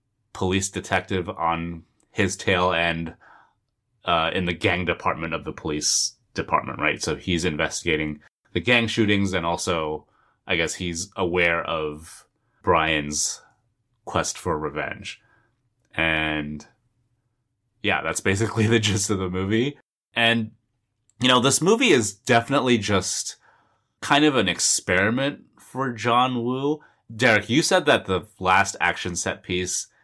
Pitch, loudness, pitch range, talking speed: 100 Hz, -22 LUFS, 85-120 Hz, 130 wpm